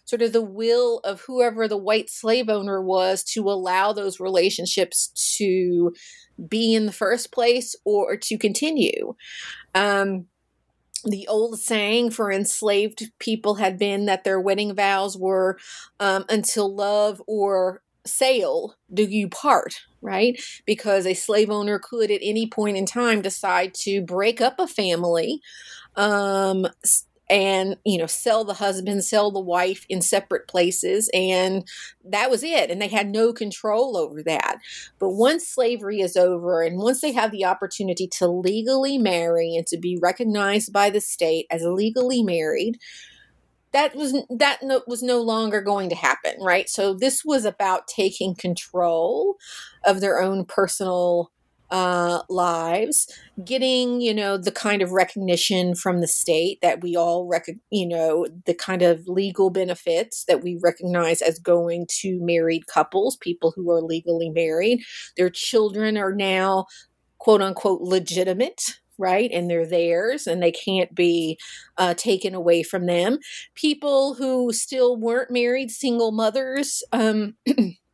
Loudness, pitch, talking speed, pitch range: -22 LUFS, 200 Hz, 150 wpm, 180-230 Hz